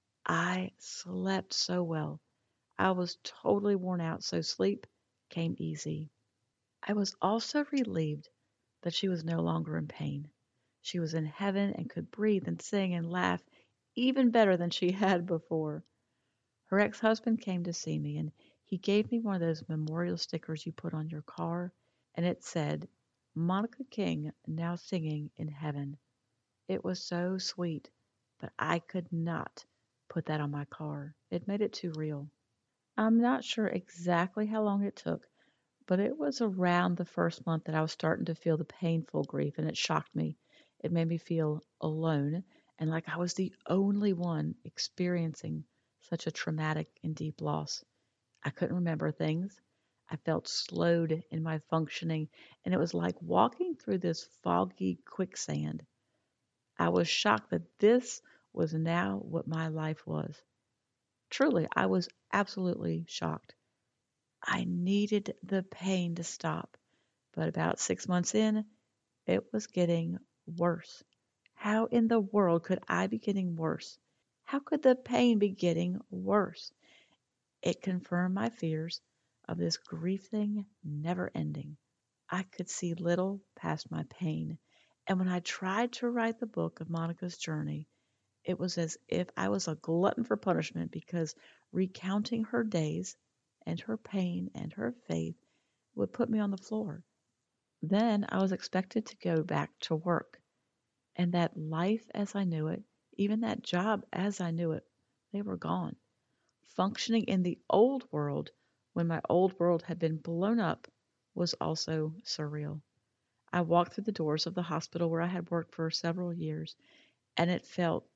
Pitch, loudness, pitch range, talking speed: 170 Hz, -33 LUFS, 155-195 Hz, 160 wpm